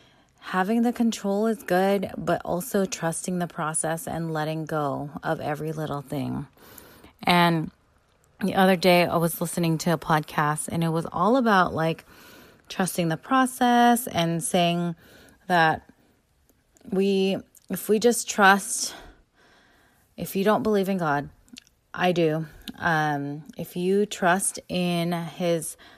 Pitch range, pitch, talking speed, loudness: 160-200 Hz, 175 Hz, 135 wpm, -24 LUFS